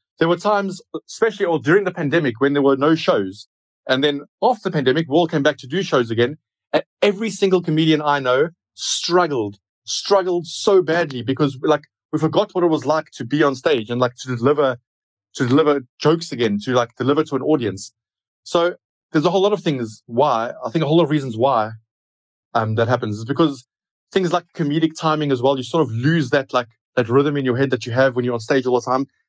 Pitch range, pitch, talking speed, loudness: 125-165 Hz, 145 Hz, 225 wpm, -19 LUFS